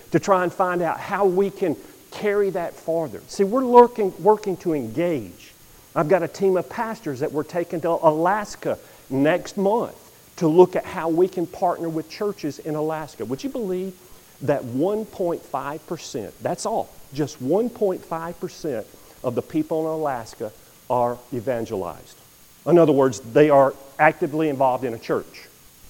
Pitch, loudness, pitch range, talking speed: 165 Hz, -22 LUFS, 150-190 Hz, 155 wpm